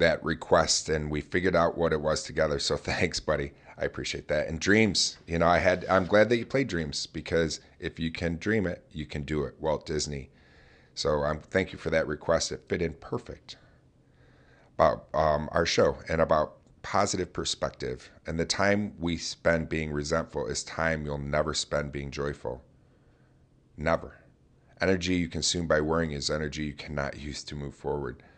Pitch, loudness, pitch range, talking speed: 80 Hz, -28 LUFS, 75-85 Hz, 185 wpm